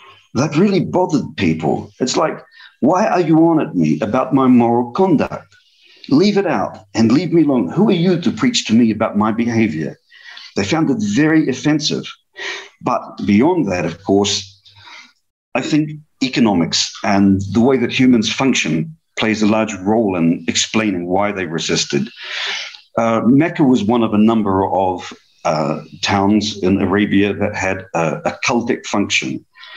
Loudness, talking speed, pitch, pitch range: -16 LUFS, 160 wpm, 110 Hz, 100-155 Hz